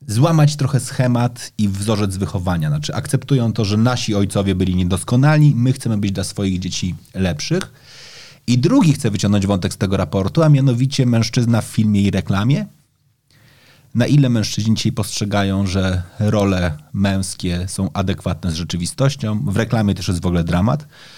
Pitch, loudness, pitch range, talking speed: 110 Hz, -18 LUFS, 95-130 Hz, 155 wpm